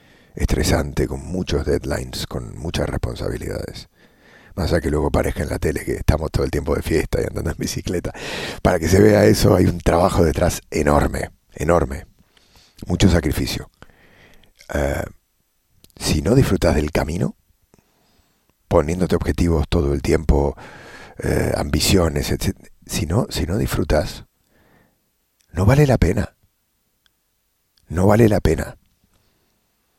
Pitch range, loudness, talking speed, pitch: 80-100 Hz, -20 LUFS, 130 wpm, 90 Hz